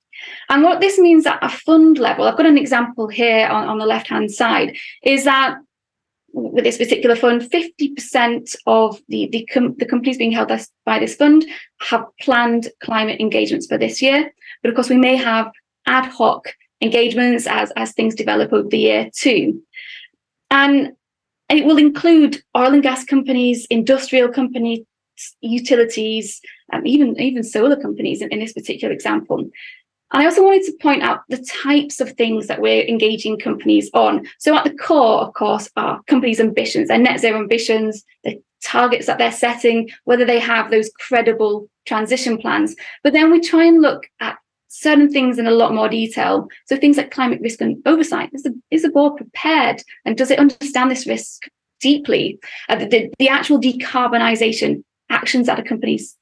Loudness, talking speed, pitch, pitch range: -16 LUFS, 175 wpm, 255 Hz, 230-290 Hz